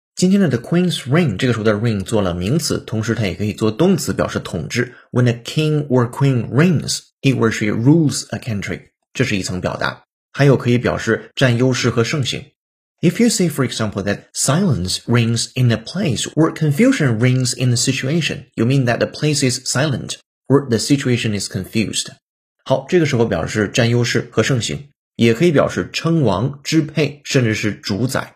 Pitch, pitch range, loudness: 125 Hz, 115-150 Hz, -17 LUFS